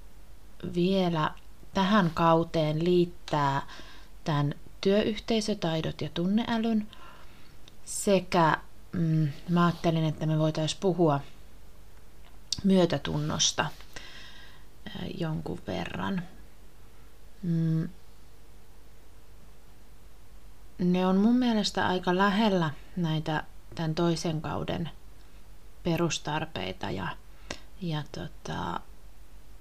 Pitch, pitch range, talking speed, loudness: 165 Hz, 150-185 Hz, 70 wpm, -28 LUFS